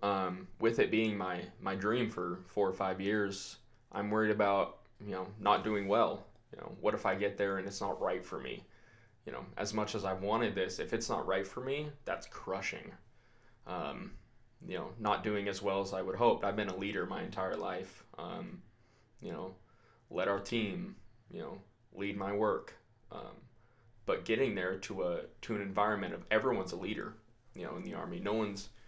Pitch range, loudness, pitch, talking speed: 95-110 Hz, -36 LUFS, 100 Hz, 205 wpm